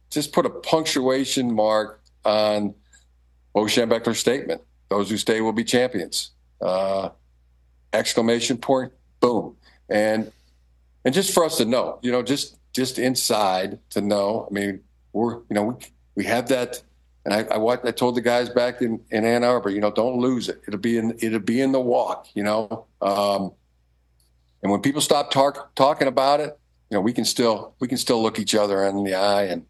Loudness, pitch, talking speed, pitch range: -22 LUFS, 110 Hz, 190 wpm, 95-125 Hz